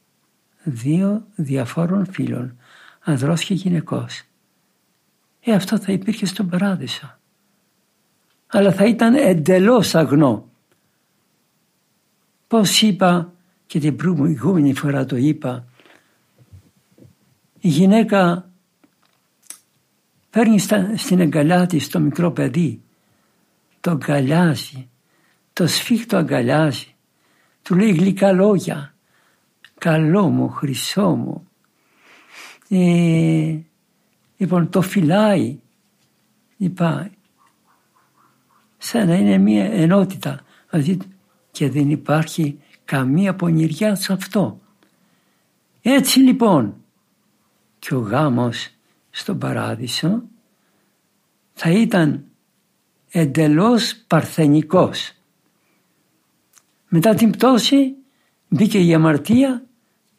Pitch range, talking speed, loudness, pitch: 155-205 Hz, 80 wpm, -17 LUFS, 180 Hz